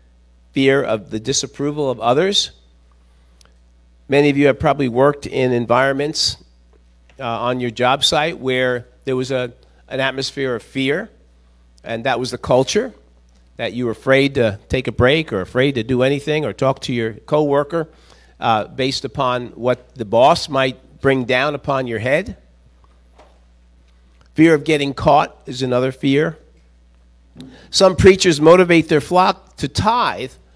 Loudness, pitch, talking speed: -17 LUFS, 125 Hz, 150 wpm